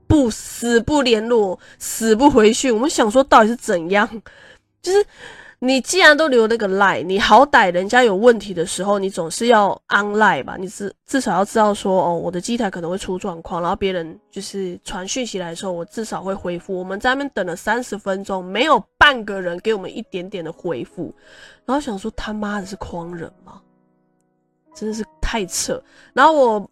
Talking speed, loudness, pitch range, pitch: 305 characters per minute, -18 LUFS, 185-235 Hz, 205 Hz